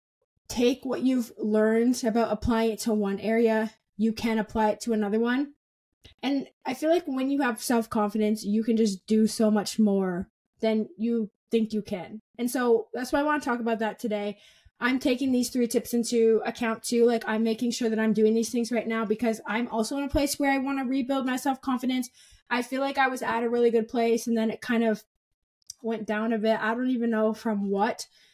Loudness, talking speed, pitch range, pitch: -26 LUFS, 220 wpm, 220-250 Hz, 230 Hz